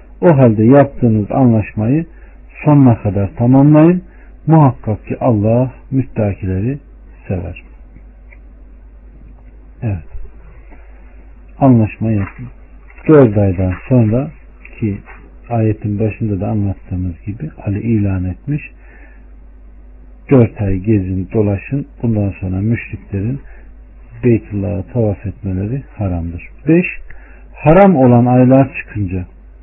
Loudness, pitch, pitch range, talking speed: -14 LUFS, 105 Hz, 90-125 Hz, 85 wpm